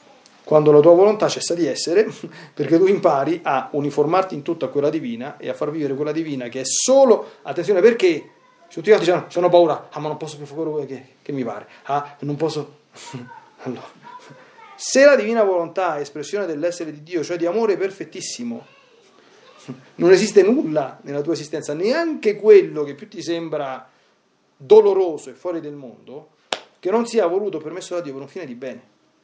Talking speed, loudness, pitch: 180 wpm, -19 LUFS, 170 Hz